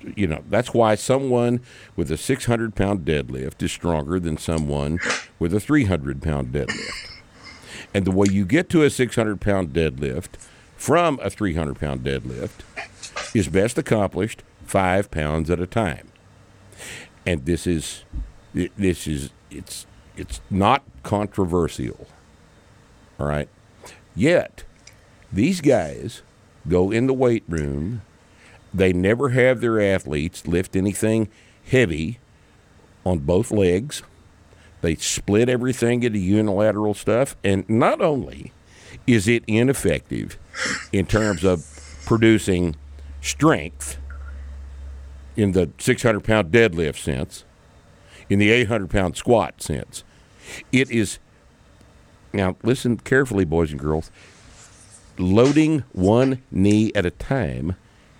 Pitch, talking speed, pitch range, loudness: 95 Hz, 115 wpm, 80-115 Hz, -21 LUFS